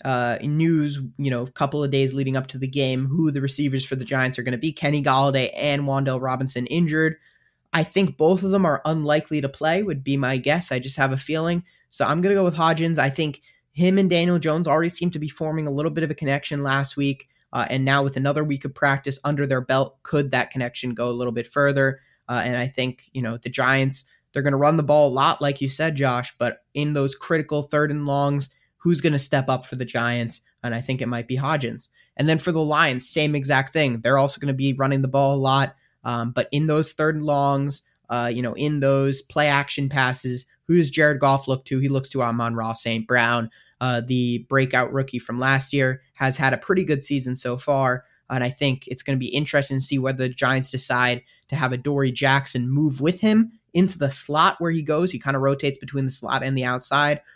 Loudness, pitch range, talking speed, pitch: -21 LUFS, 130-150 Hz, 245 wpm, 140 Hz